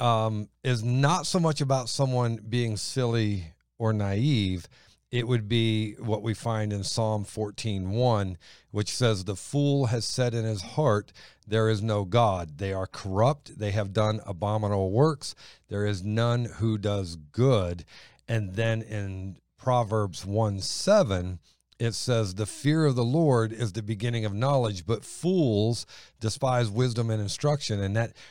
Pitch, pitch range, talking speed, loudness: 110 Hz, 105-120 Hz, 155 wpm, -27 LUFS